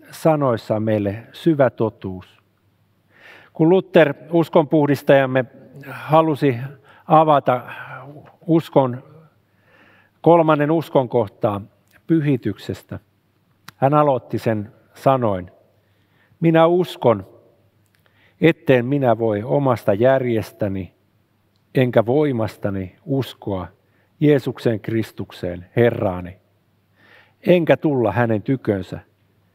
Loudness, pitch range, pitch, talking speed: -19 LUFS, 105-145 Hz, 120 Hz, 70 wpm